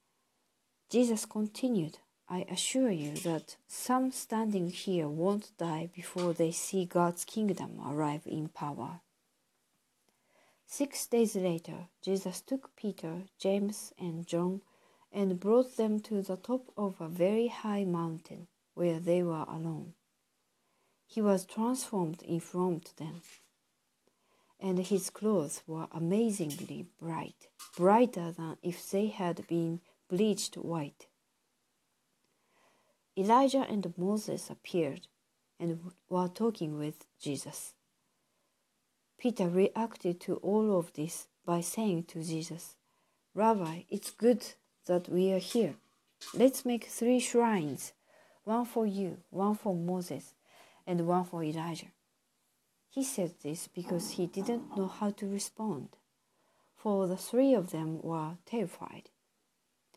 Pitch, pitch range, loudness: 185 Hz, 170-215 Hz, -33 LUFS